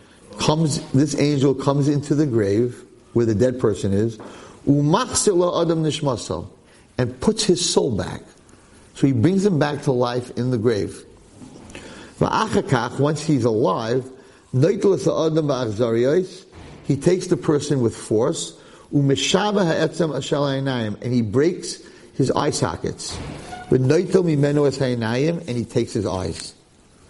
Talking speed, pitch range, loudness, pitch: 105 wpm, 120-155 Hz, -20 LUFS, 140 Hz